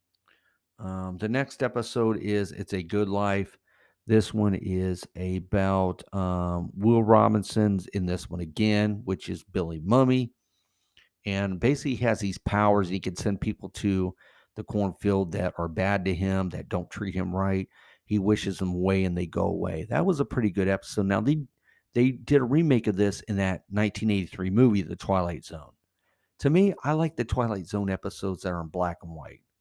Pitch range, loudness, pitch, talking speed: 95-110 Hz, -27 LUFS, 100 Hz, 180 wpm